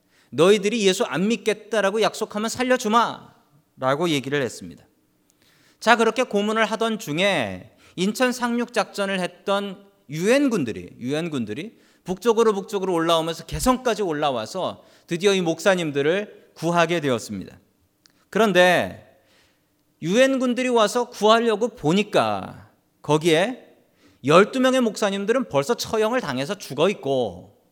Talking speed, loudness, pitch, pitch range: 295 characters per minute, -22 LUFS, 200 Hz, 165-225 Hz